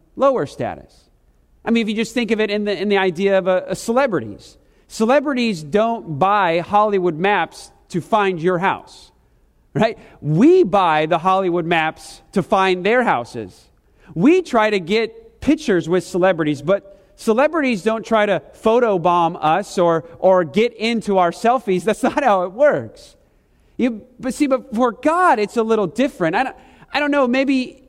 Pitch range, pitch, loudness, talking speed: 180-245 Hz, 205 Hz, -18 LUFS, 170 wpm